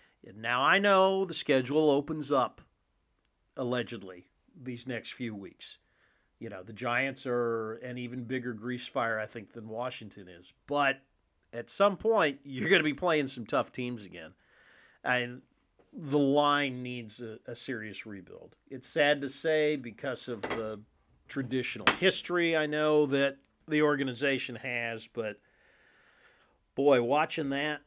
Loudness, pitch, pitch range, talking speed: -30 LUFS, 125 Hz, 115-150 Hz, 145 wpm